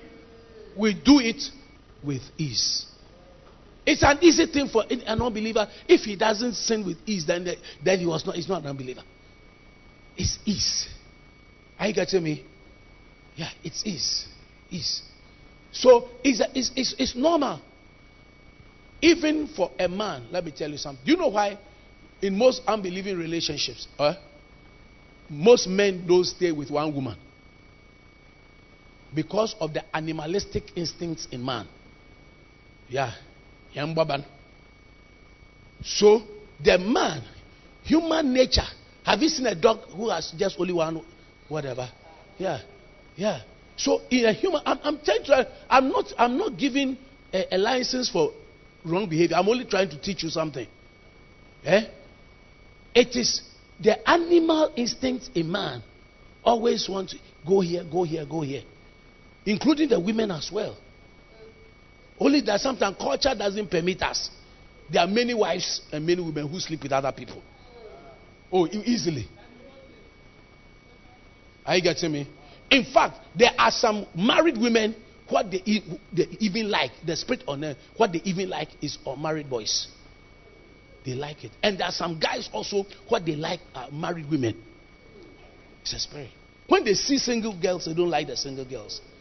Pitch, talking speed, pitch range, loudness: 185 Hz, 150 wpm, 150-235 Hz, -25 LUFS